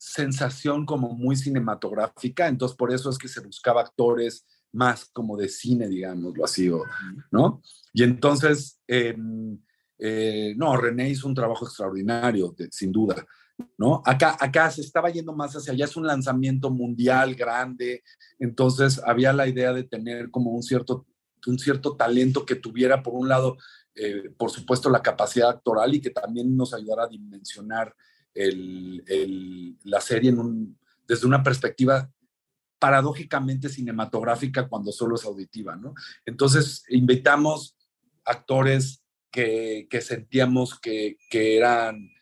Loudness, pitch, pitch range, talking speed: -24 LUFS, 125 Hz, 115-135 Hz, 145 wpm